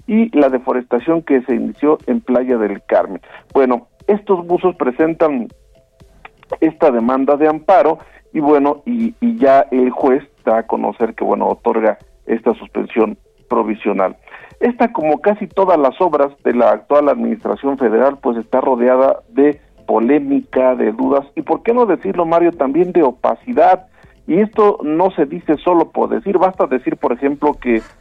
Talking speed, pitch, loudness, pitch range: 160 wpm, 145 Hz, -15 LUFS, 130-185 Hz